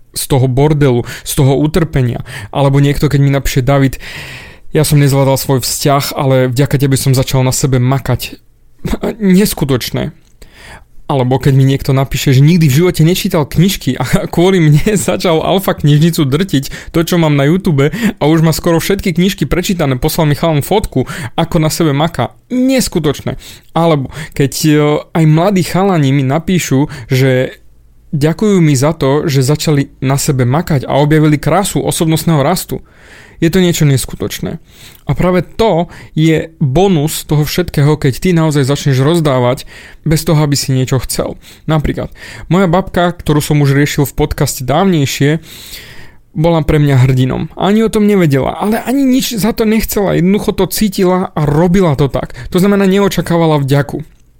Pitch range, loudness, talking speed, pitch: 140-175 Hz, -12 LUFS, 160 wpm, 155 Hz